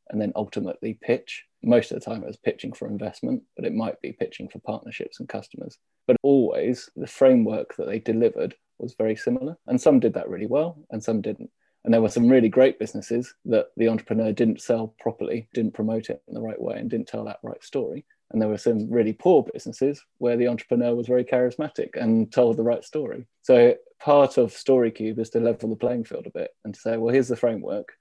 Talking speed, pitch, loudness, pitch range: 225 wpm, 120 Hz, -24 LUFS, 115-140 Hz